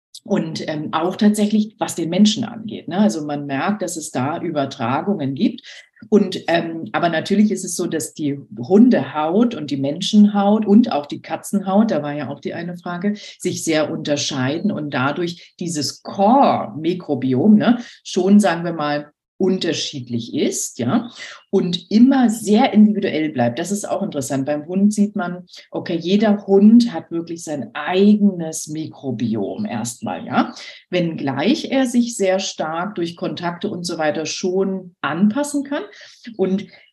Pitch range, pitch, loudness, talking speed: 155-205 Hz, 180 Hz, -19 LUFS, 150 wpm